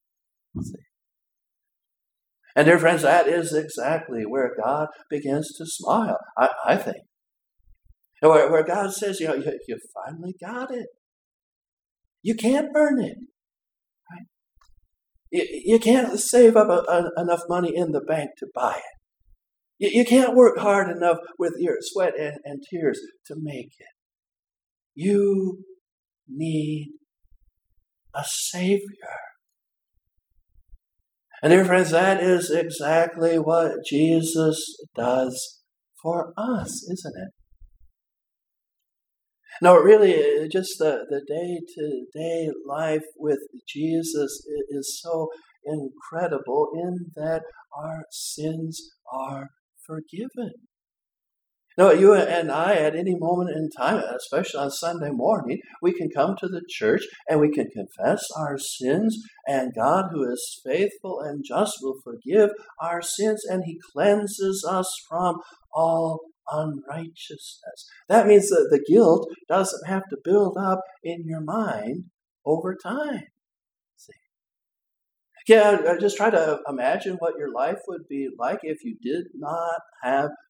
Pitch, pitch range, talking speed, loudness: 170 Hz, 150-205 Hz, 125 wpm, -22 LUFS